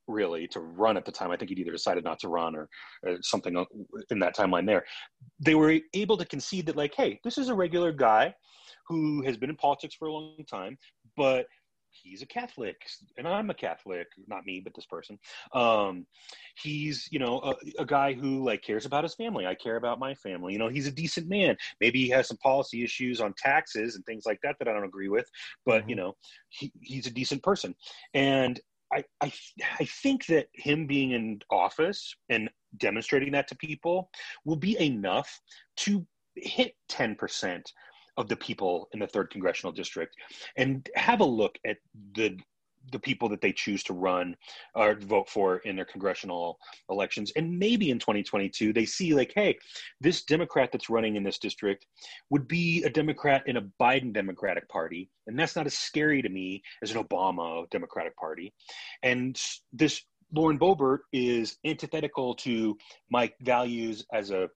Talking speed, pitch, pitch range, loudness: 185 wpm, 135 Hz, 110-155 Hz, -29 LUFS